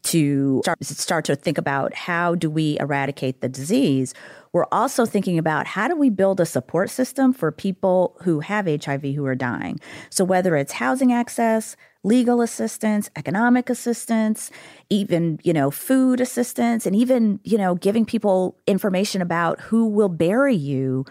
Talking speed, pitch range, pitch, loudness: 160 wpm, 150-230 Hz, 185 Hz, -21 LUFS